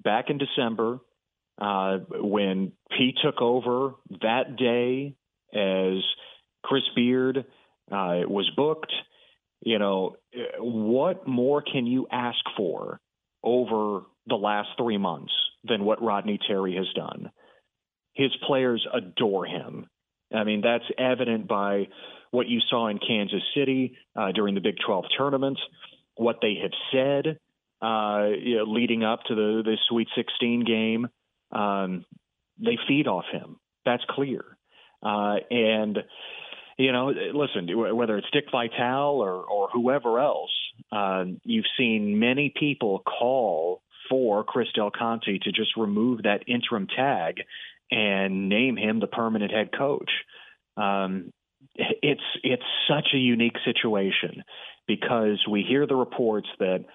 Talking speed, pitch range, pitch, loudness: 135 wpm, 105-130 Hz, 115 Hz, -26 LUFS